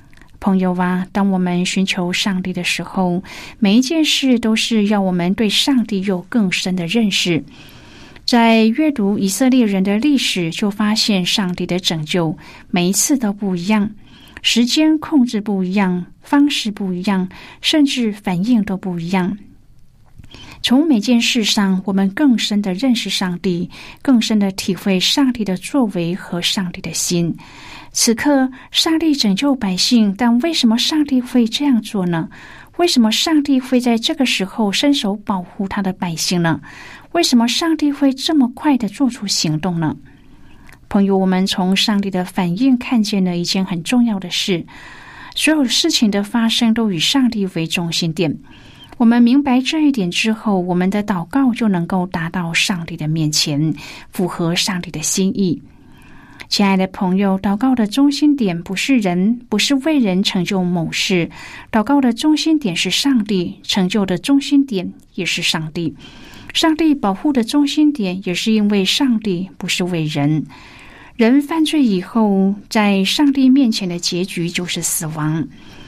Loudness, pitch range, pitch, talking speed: -16 LUFS, 180-245 Hz, 200 Hz, 240 characters per minute